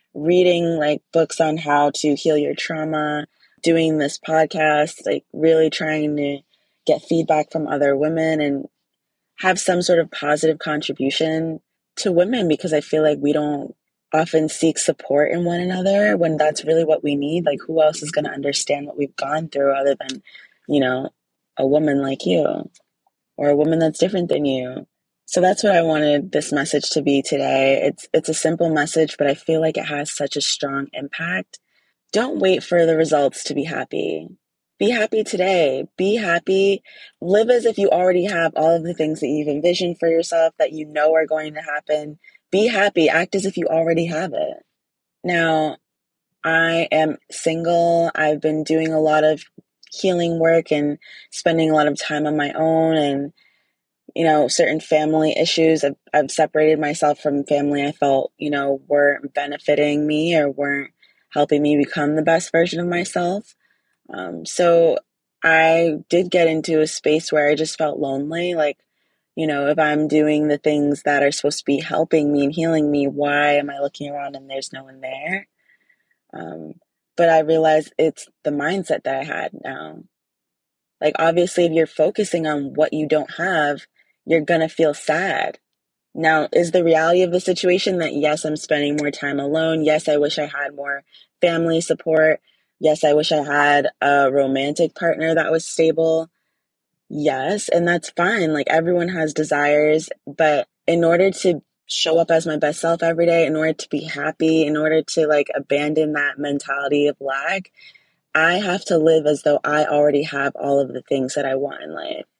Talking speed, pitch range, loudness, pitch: 185 wpm, 145-165 Hz, -19 LUFS, 155 Hz